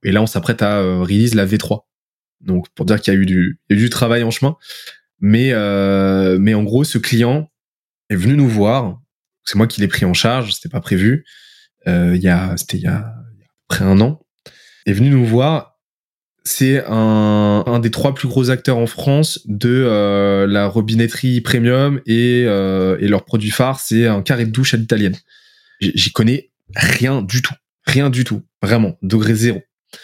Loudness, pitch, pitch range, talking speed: -15 LUFS, 115 Hz, 100-130 Hz, 195 wpm